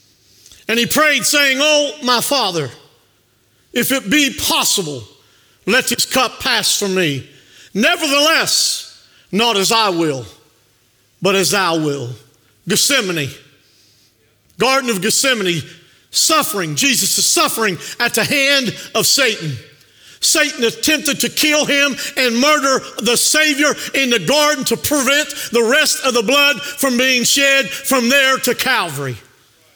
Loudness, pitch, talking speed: -14 LUFS, 230 Hz, 130 wpm